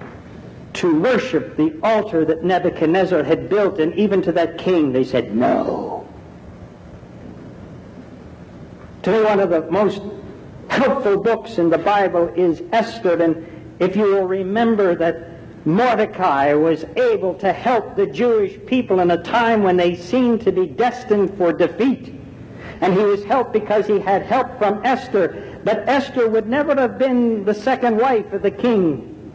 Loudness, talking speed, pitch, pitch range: -18 LUFS, 155 wpm, 195 Hz, 170-230 Hz